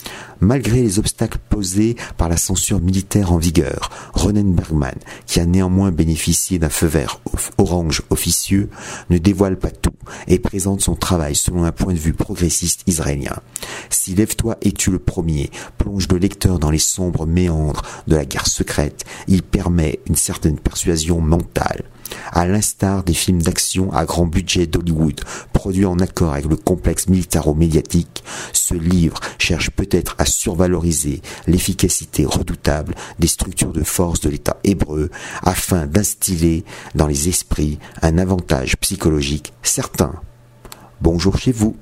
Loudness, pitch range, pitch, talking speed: -18 LUFS, 80-95 Hz, 90 Hz, 145 wpm